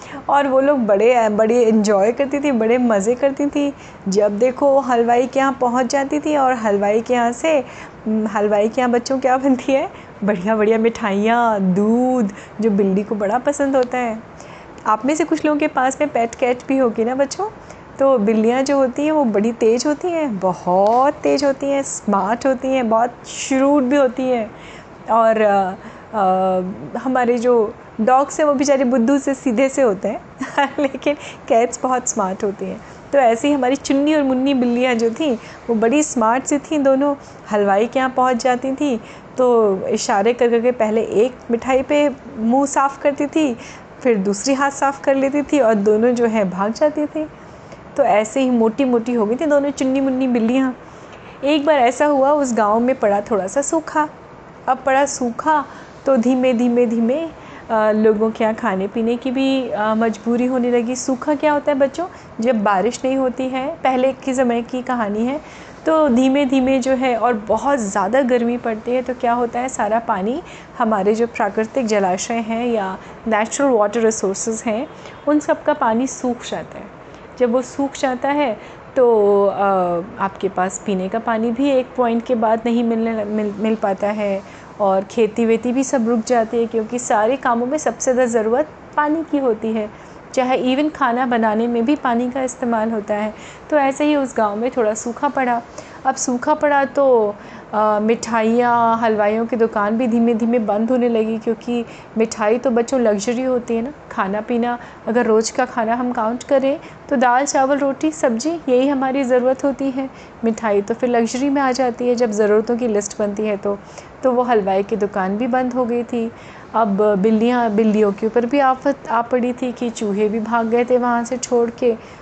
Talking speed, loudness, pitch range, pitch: 190 wpm, -18 LUFS, 220-270 Hz, 245 Hz